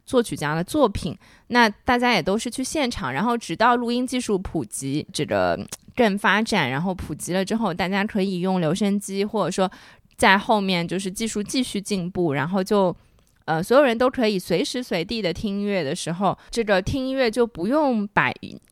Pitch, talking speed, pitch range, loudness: 200 Hz, 285 characters per minute, 180-235 Hz, -22 LUFS